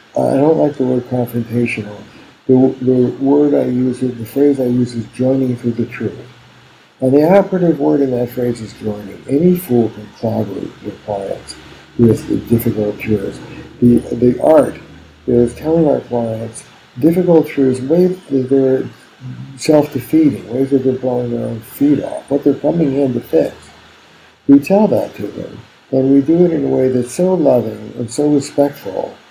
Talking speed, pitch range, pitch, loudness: 170 wpm, 120-145 Hz, 130 Hz, -15 LUFS